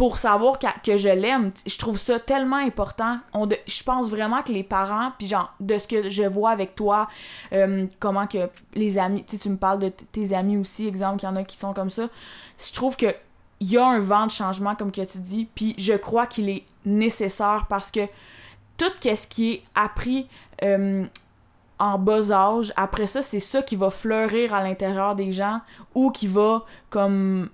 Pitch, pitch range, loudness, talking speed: 210 Hz, 195-225 Hz, -23 LUFS, 210 wpm